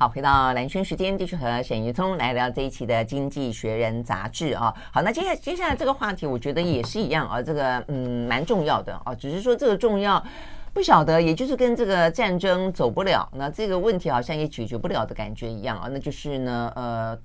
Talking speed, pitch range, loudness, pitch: 340 characters per minute, 120-190 Hz, -24 LUFS, 140 Hz